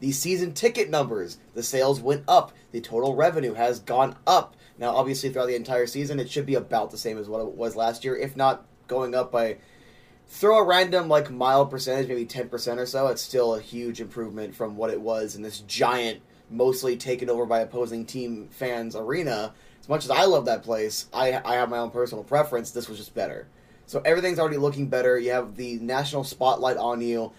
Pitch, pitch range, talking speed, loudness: 125 Hz, 115-135 Hz, 215 wpm, -25 LUFS